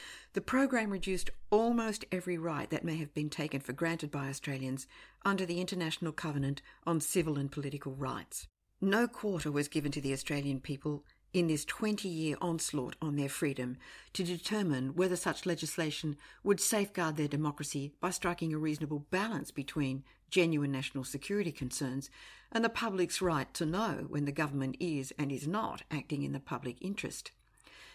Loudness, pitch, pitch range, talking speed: -35 LUFS, 155 Hz, 140-185 Hz, 165 wpm